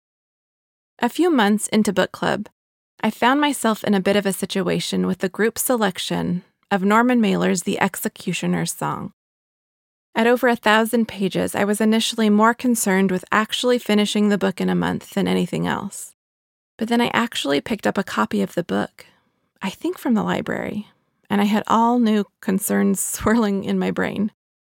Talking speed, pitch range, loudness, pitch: 175 wpm, 190-225 Hz, -20 LUFS, 210 Hz